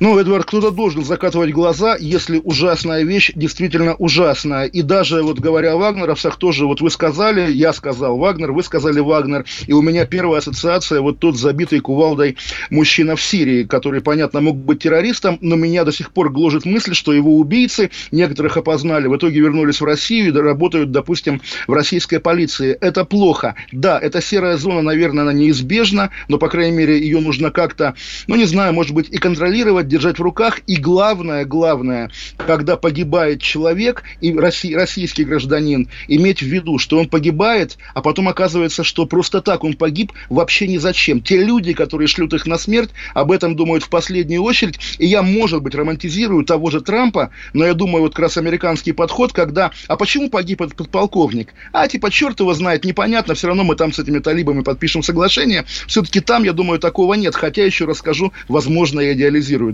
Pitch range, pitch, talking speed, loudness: 155-185 Hz, 165 Hz, 185 wpm, -15 LUFS